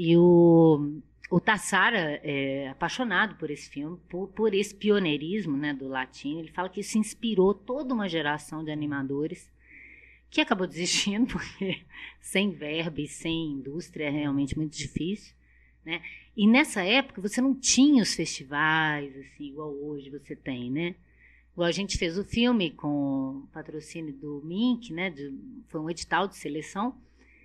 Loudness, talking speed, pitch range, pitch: -27 LUFS, 155 wpm, 145-200 Hz, 165 Hz